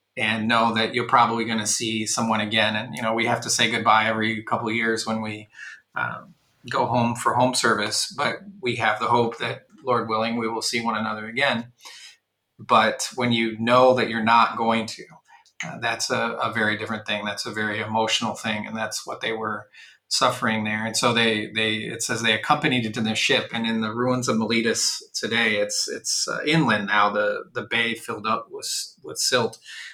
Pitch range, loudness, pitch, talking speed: 110-120 Hz, -22 LUFS, 115 Hz, 210 wpm